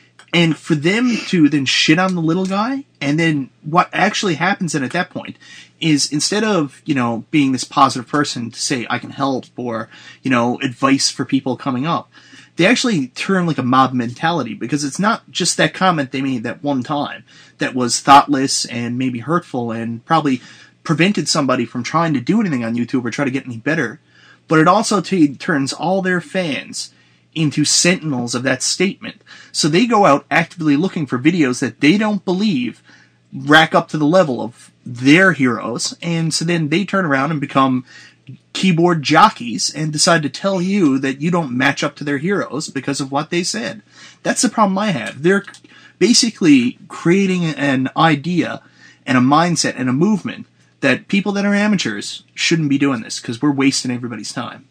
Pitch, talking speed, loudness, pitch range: 155 Hz, 190 wpm, -16 LUFS, 135-185 Hz